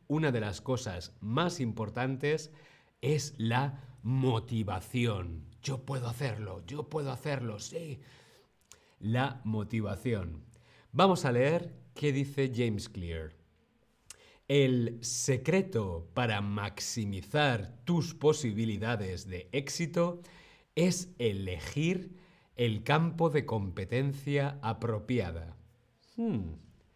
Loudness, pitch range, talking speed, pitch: -33 LUFS, 105-145 Hz, 90 wpm, 120 Hz